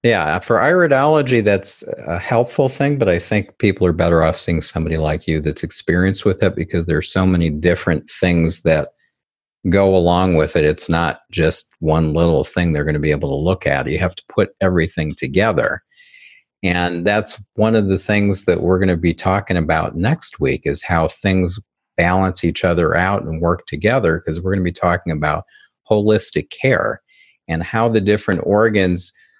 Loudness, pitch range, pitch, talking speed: -17 LUFS, 80-105 Hz, 90 Hz, 190 wpm